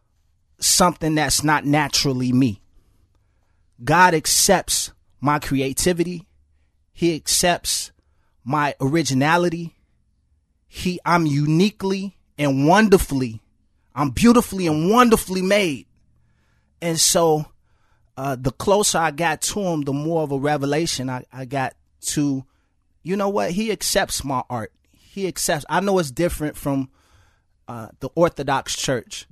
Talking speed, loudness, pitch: 120 wpm, -20 LUFS, 145 Hz